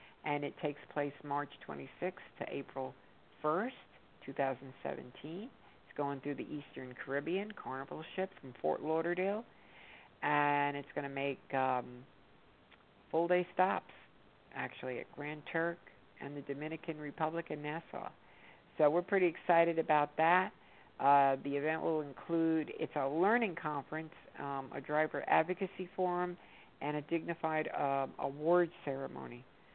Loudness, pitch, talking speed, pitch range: -36 LUFS, 150 Hz, 135 wpm, 140-170 Hz